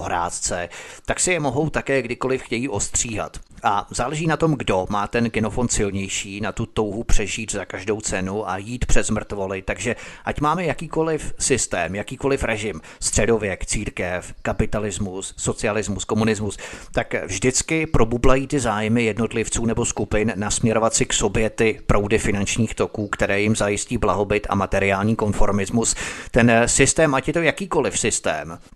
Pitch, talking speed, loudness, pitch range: 110 Hz, 150 wpm, -22 LUFS, 100-120 Hz